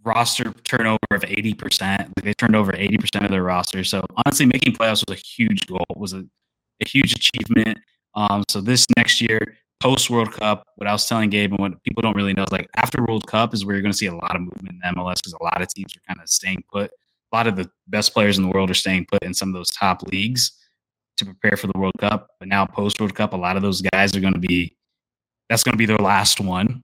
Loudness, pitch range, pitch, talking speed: -20 LUFS, 95-110 Hz, 100 Hz, 255 wpm